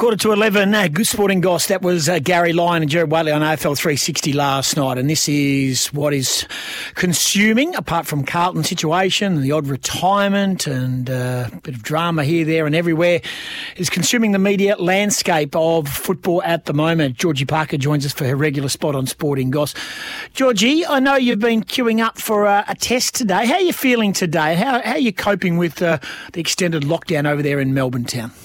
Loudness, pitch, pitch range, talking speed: -17 LUFS, 170 Hz, 150-200 Hz, 205 wpm